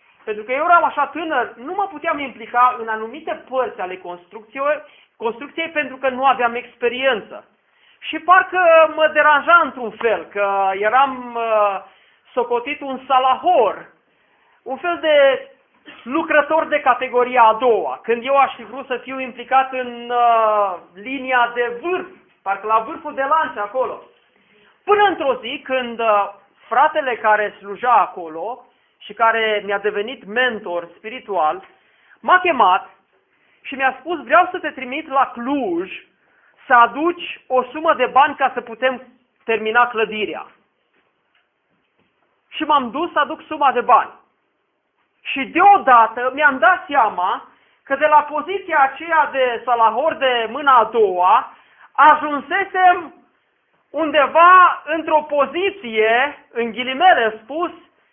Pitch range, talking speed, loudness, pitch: 235-315 Hz, 130 wpm, -17 LUFS, 265 Hz